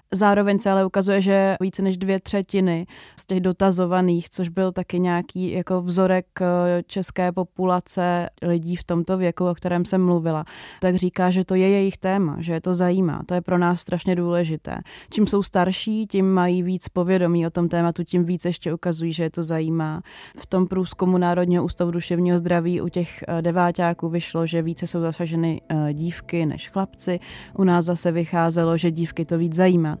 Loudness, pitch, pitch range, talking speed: -22 LUFS, 180 Hz, 170-185 Hz, 180 wpm